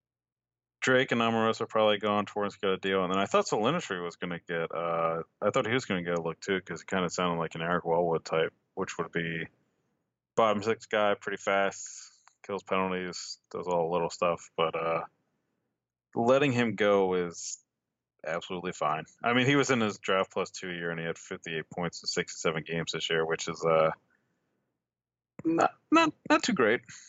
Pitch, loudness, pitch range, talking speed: 95 Hz, -29 LUFS, 85-110 Hz, 205 wpm